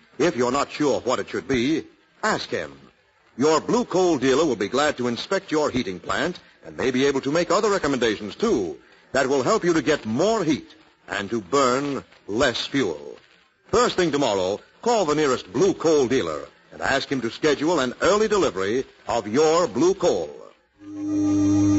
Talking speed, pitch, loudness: 180 wpm, 205 Hz, -22 LUFS